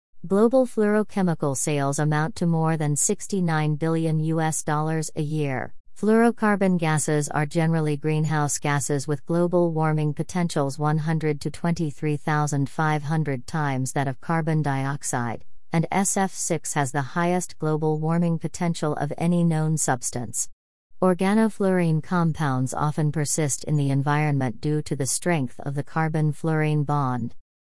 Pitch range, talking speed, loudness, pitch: 145-170 Hz, 130 wpm, -24 LUFS, 155 Hz